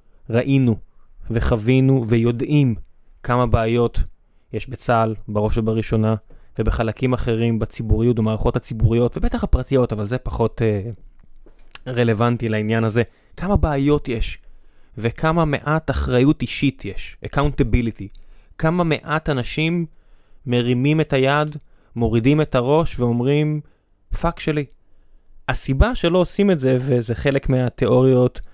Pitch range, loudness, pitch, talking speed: 115-140 Hz, -20 LUFS, 120 Hz, 110 wpm